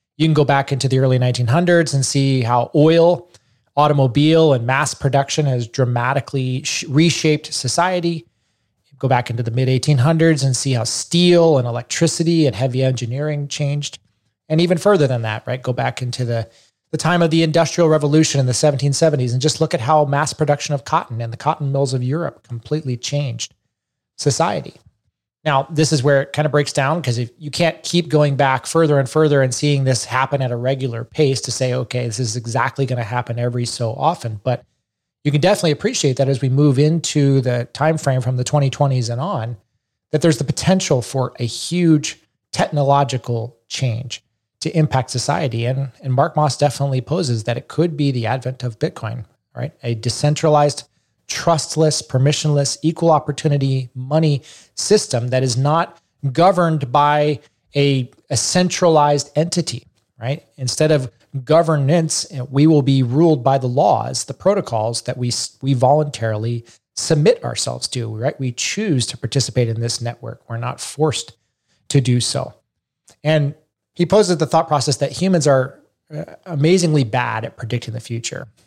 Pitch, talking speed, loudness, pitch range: 140 Hz, 170 wpm, -18 LUFS, 125-155 Hz